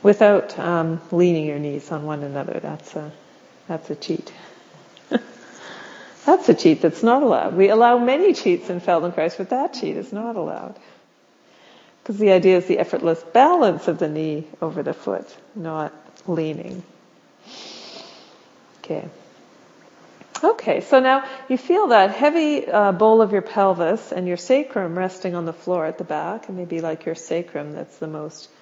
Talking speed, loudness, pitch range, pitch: 160 wpm, -20 LUFS, 165-225 Hz, 185 Hz